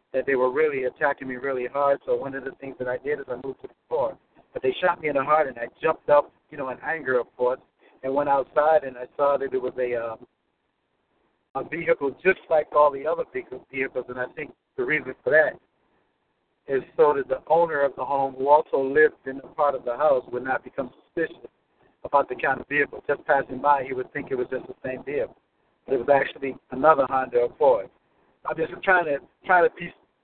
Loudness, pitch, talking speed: -24 LUFS, 145 Hz, 230 wpm